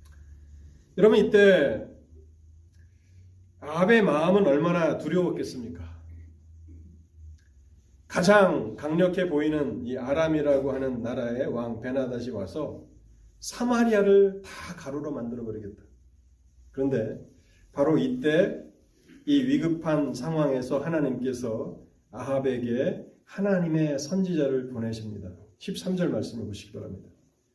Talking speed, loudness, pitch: 240 characters per minute, -25 LUFS, 130 Hz